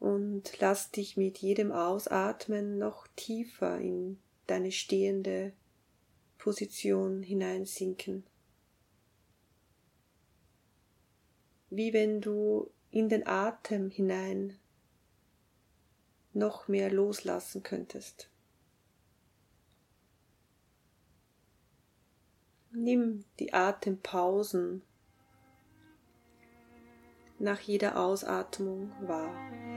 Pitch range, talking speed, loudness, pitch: 185-210 Hz, 60 wpm, -33 LUFS, 195 Hz